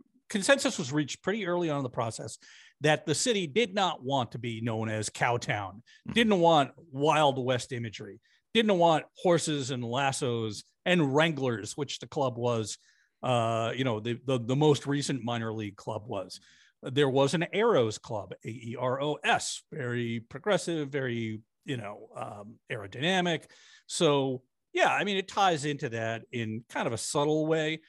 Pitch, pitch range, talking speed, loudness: 140 Hz, 120-160 Hz, 160 wpm, -29 LUFS